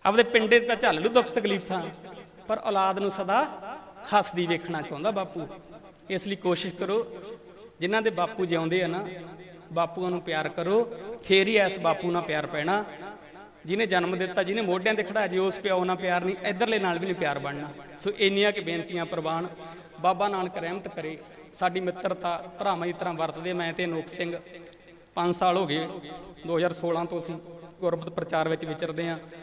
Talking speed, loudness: 175 wpm, -27 LUFS